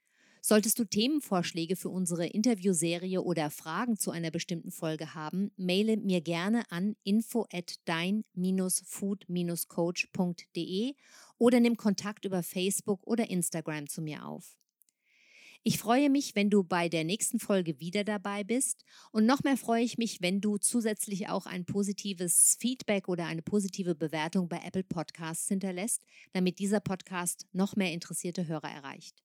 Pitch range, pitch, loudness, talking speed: 175-215 Hz, 190 Hz, -31 LUFS, 145 wpm